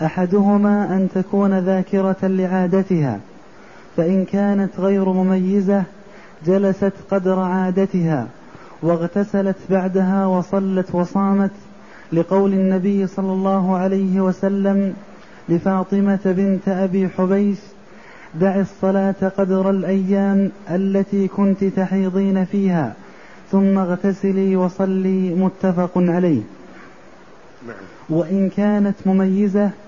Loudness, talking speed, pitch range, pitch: -18 LUFS, 85 wpm, 185-195 Hz, 190 Hz